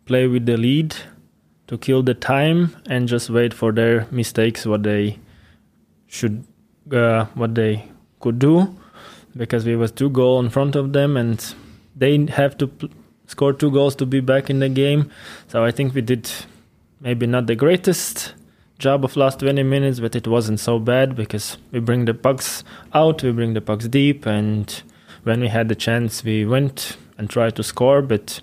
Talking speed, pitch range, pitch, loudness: 185 wpm, 115-135 Hz, 120 Hz, -19 LUFS